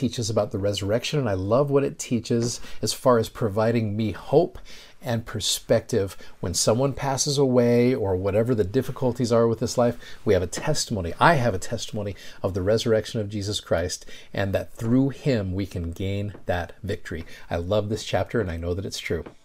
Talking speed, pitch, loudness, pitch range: 195 wpm, 115 Hz, -24 LUFS, 105-125 Hz